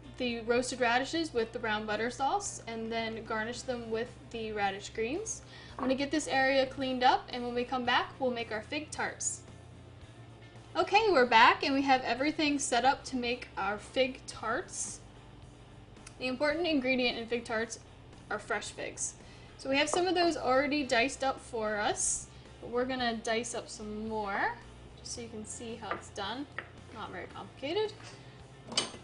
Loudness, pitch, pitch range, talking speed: -32 LUFS, 245 Hz, 225-270 Hz, 180 wpm